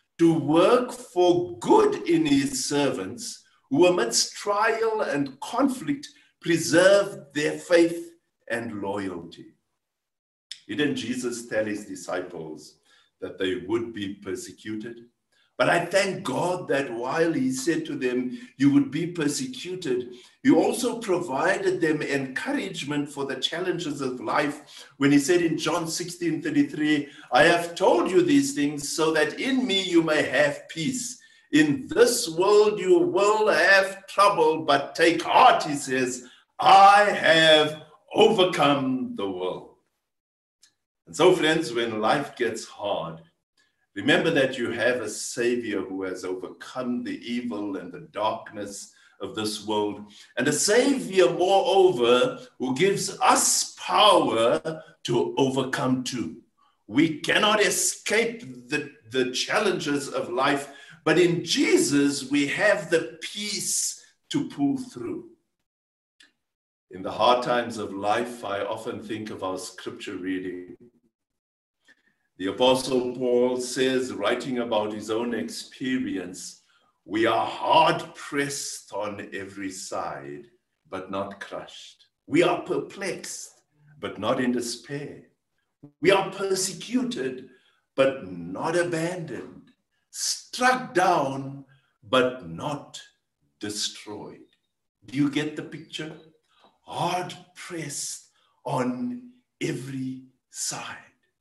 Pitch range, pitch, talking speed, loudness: 125-205 Hz, 155 Hz, 120 wpm, -24 LUFS